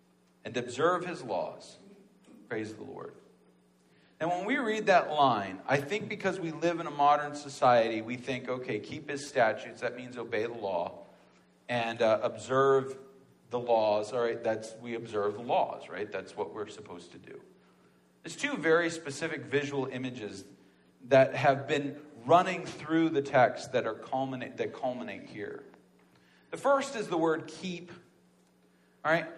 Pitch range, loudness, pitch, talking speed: 105-160 Hz, -30 LUFS, 135 Hz, 155 wpm